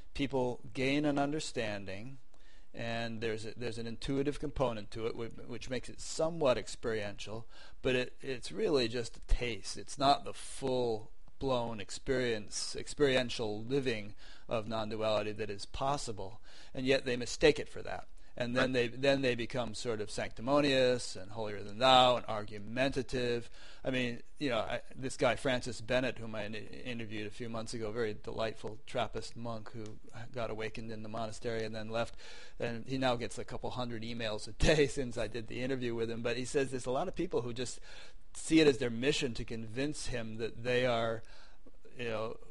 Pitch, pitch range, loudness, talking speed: 120 Hz, 110-130 Hz, -35 LUFS, 185 wpm